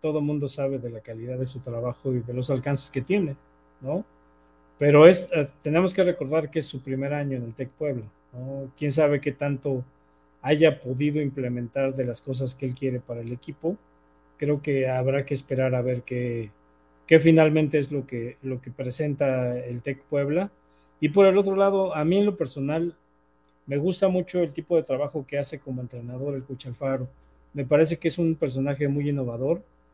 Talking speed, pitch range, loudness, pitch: 195 wpm, 125-150 Hz, -25 LUFS, 135 Hz